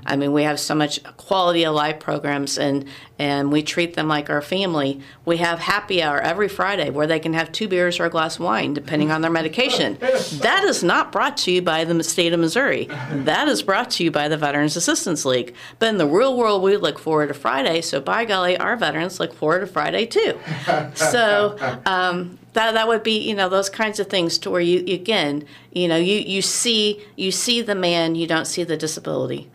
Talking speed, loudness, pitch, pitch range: 225 wpm, -20 LUFS, 170 Hz, 150-195 Hz